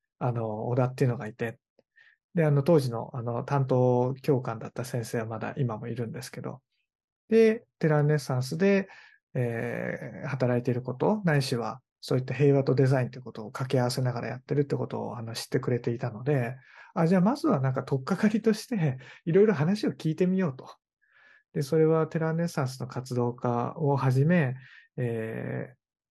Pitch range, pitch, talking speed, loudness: 120-165 Hz, 135 Hz, 375 characters per minute, -28 LUFS